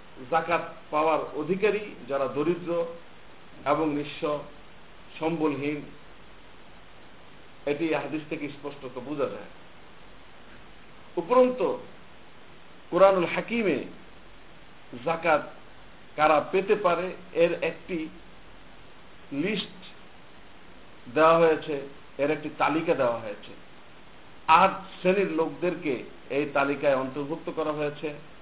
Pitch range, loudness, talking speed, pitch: 145-170 Hz, -27 LUFS, 80 wpm, 155 Hz